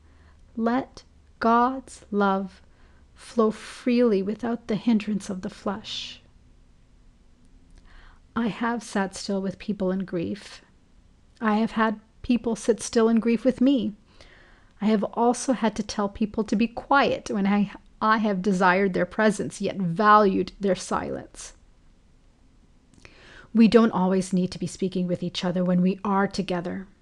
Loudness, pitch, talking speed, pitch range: -24 LUFS, 205 Hz, 140 wpm, 185-230 Hz